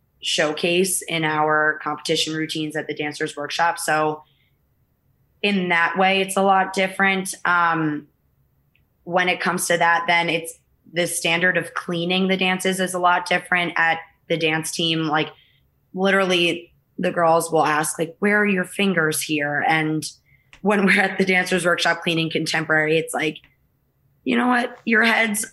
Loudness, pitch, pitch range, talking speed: -20 LUFS, 170 Hz, 155-185 Hz, 155 wpm